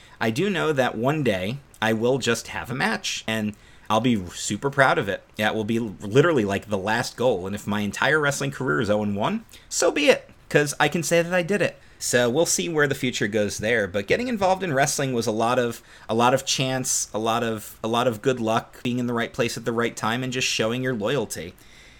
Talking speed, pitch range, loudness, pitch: 245 wpm, 110-135 Hz, -23 LUFS, 120 Hz